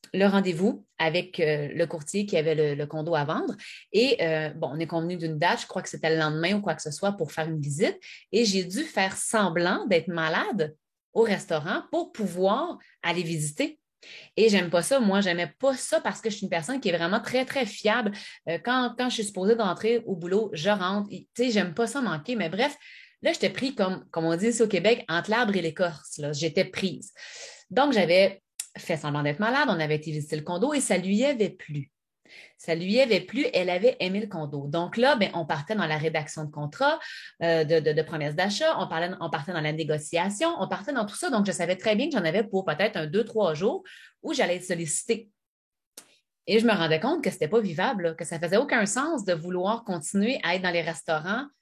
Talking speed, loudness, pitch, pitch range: 235 wpm, -26 LUFS, 190 Hz, 165-225 Hz